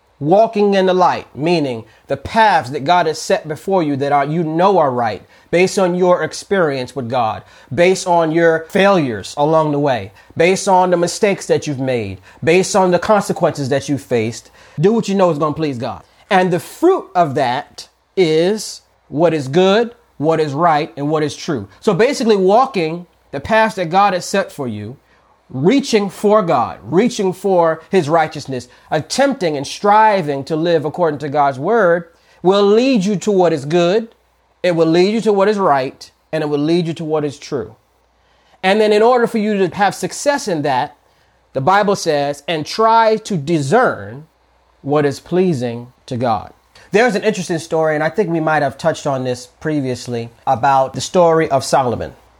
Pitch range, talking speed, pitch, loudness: 145-195 Hz, 190 wpm, 170 Hz, -15 LUFS